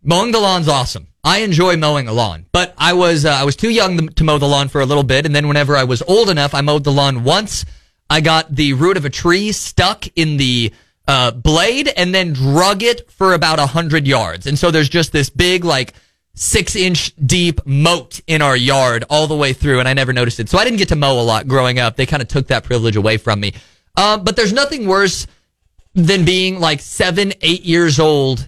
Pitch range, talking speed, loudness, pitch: 130-175 Hz, 235 wpm, -14 LUFS, 150 Hz